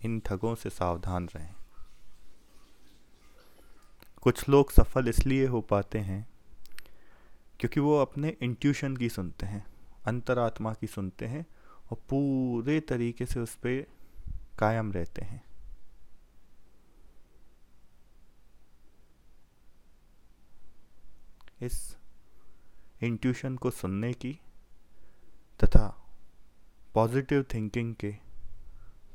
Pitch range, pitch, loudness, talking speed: 100-125 Hz, 115 Hz, -31 LUFS, 85 wpm